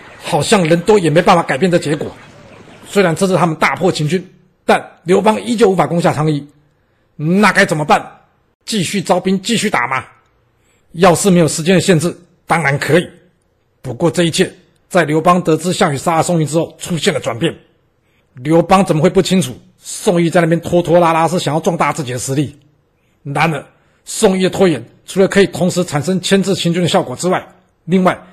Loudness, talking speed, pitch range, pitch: -14 LUFS, 290 characters per minute, 150-185 Hz, 170 Hz